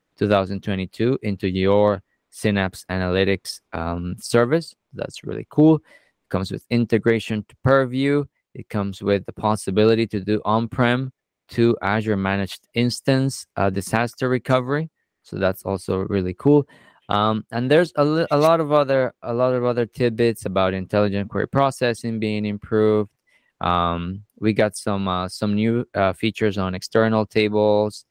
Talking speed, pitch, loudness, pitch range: 145 wpm, 110 Hz, -21 LUFS, 100-120 Hz